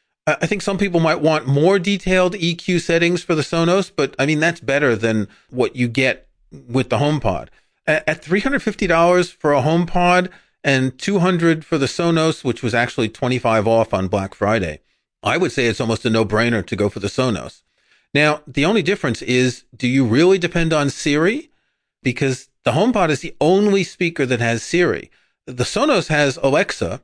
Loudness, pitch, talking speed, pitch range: -18 LUFS, 150 Hz, 180 wpm, 125-175 Hz